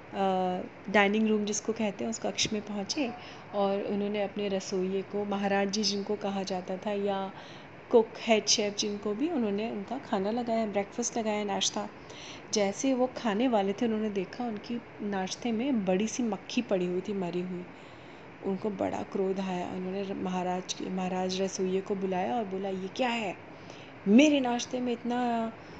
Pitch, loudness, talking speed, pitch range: 205 Hz, -30 LUFS, 165 wpm, 195-225 Hz